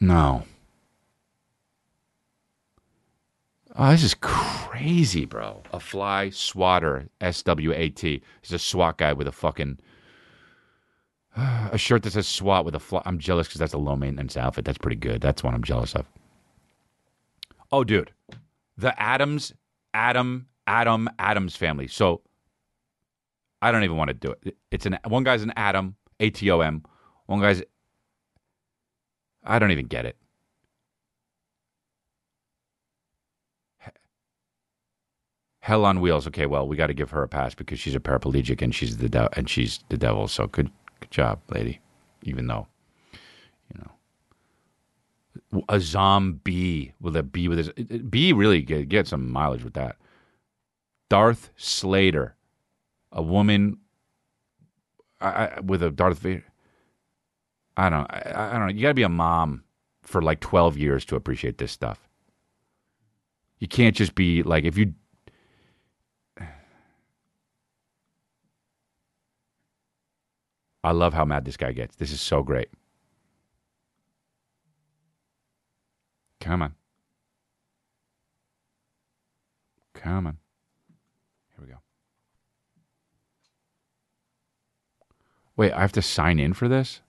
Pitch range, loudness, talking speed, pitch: 75-105 Hz, -24 LUFS, 130 wpm, 90 Hz